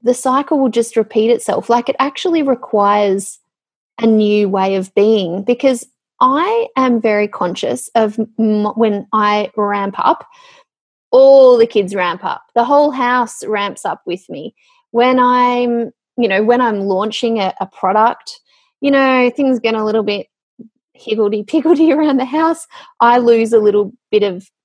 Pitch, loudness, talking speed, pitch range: 235 Hz, -14 LUFS, 160 wpm, 210-270 Hz